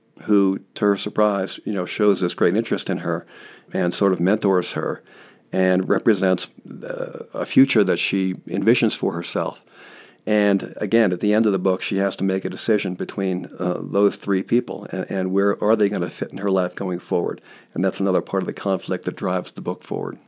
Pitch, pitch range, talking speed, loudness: 95 Hz, 95-105 Hz, 210 wpm, -22 LUFS